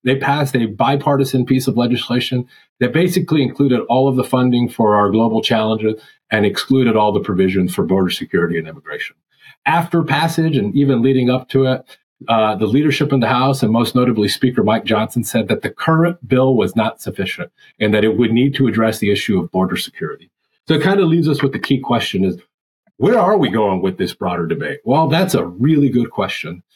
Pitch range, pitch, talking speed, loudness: 110-140 Hz, 125 Hz, 210 wpm, -16 LUFS